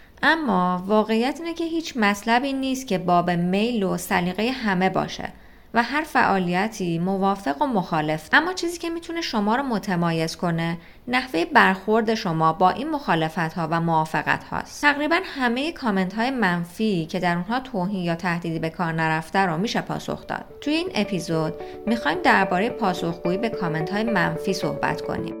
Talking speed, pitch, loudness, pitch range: 160 wpm, 195 Hz, -23 LUFS, 175-250 Hz